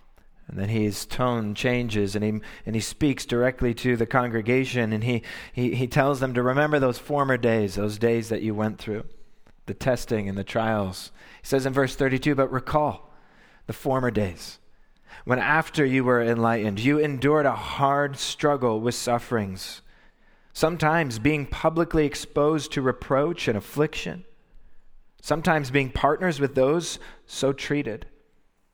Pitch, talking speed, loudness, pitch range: 130 Hz, 150 wpm, -24 LUFS, 115-145 Hz